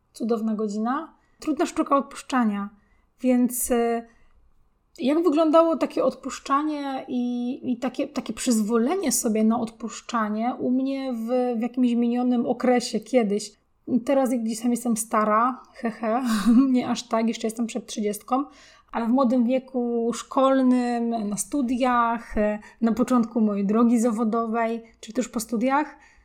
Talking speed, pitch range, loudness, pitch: 130 wpm, 230-260 Hz, -24 LUFS, 245 Hz